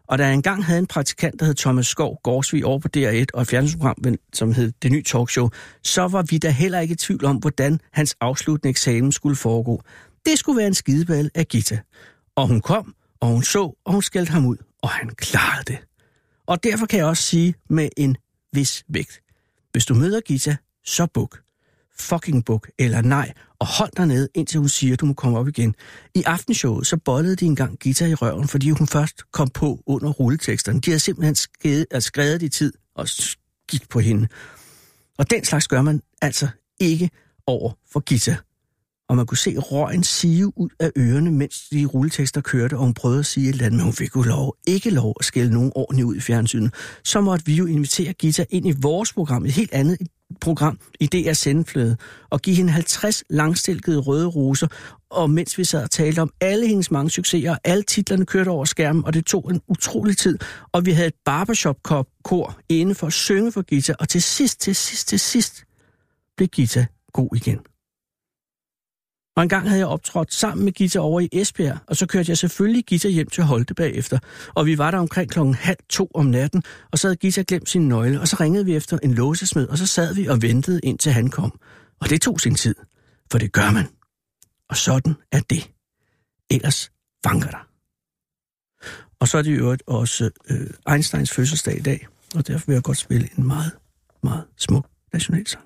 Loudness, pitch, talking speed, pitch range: -20 LUFS, 150 Hz, 205 wpm, 130-175 Hz